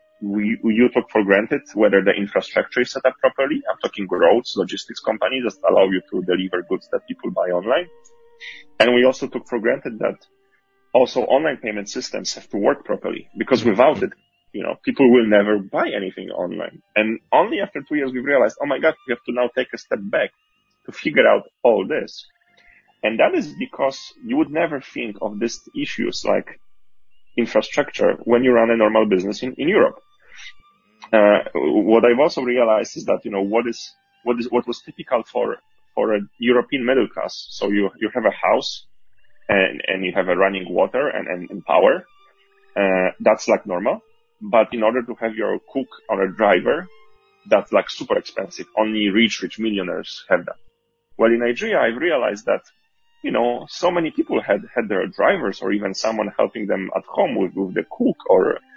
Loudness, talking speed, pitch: -20 LUFS, 195 wpm, 125 Hz